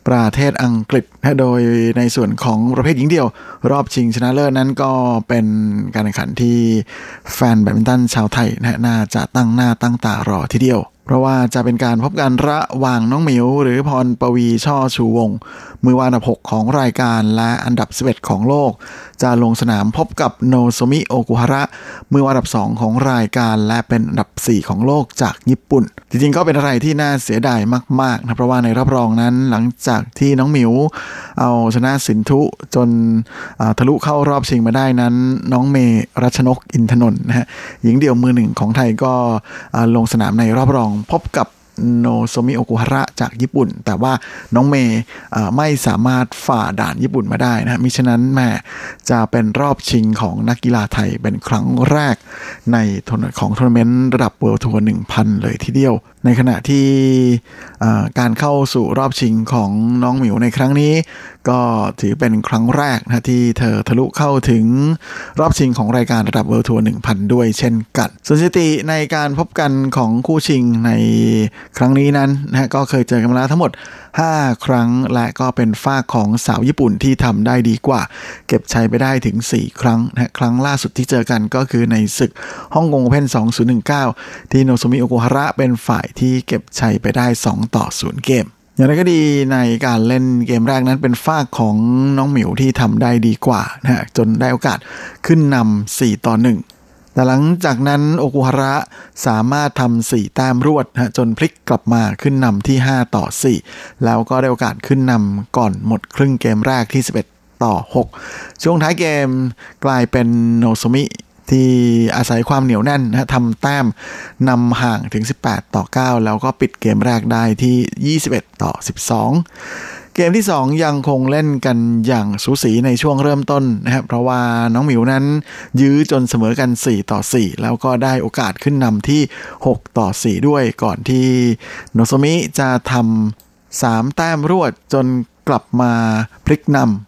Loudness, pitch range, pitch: -15 LUFS, 115-135 Hz, 125 Hz